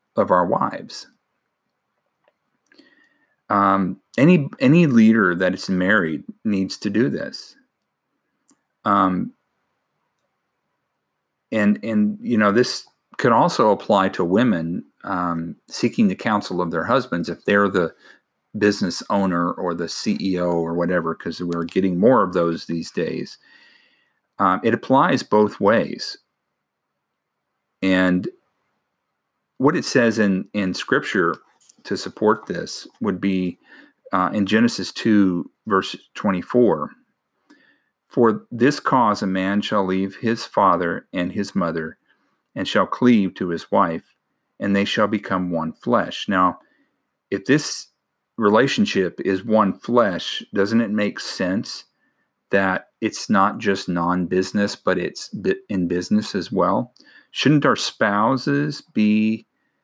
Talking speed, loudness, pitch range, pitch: 125 wpm, -20 LUFS, 90-110 Hz, 100 Hz